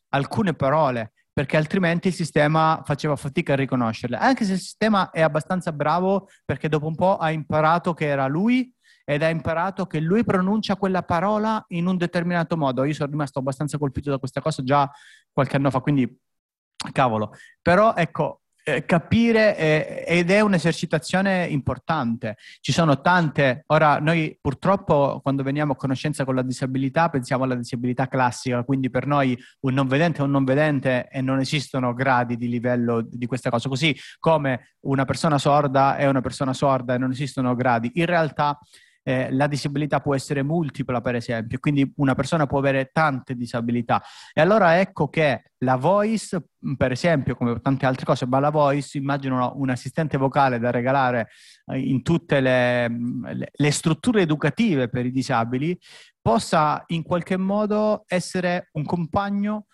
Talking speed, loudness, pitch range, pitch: 165 wpm, -22 LUFS, 130-170 Hz, 145 Hz